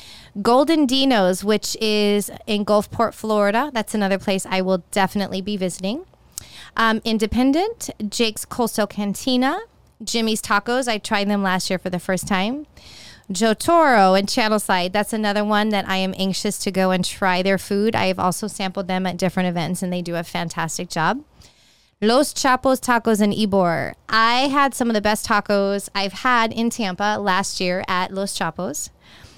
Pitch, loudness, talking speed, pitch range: 205 Hz, -20 LUFS, 170 wpm, 190-225 Hz